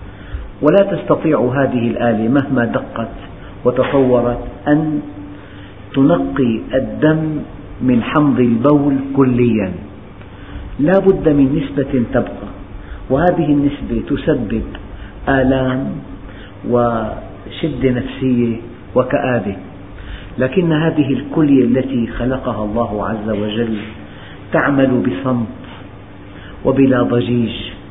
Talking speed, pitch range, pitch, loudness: 80 wpm, 100-135 Hz, 120 Hz, -16 LUFS